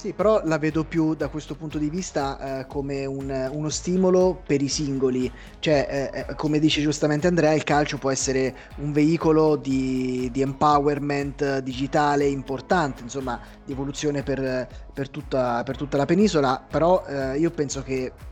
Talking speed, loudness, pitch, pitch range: 165 wpm, -24 LUFS, 145 Hz, 135-155 Hz